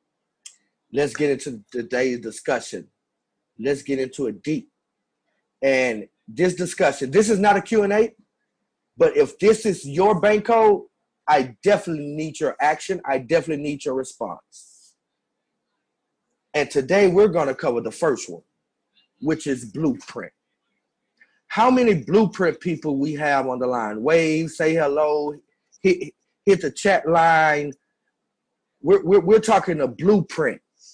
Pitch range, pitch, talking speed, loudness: 140-200 Hz, 160 Hz, 135 wpm, -21 LUFS